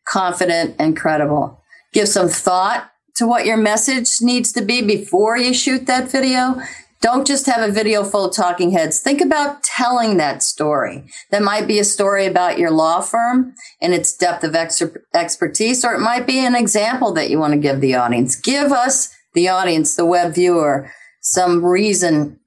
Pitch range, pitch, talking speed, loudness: 175-245 Hz, 205 Hz, 185 wpm, -16 LUFS